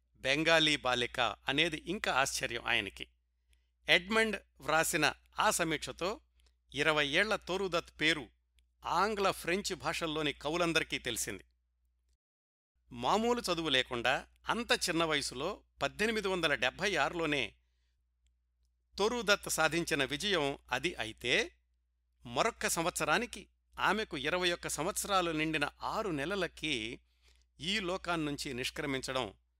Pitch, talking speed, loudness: 150 Hz, 95 wpm, -33 LUFS